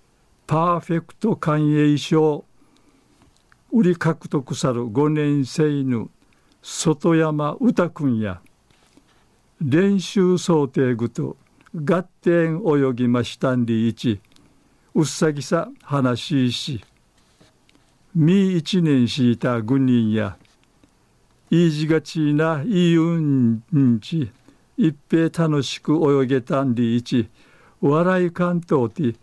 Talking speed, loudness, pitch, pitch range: 180 characters per minute, -20 LUFS, 150 Hz, 125-170 Hz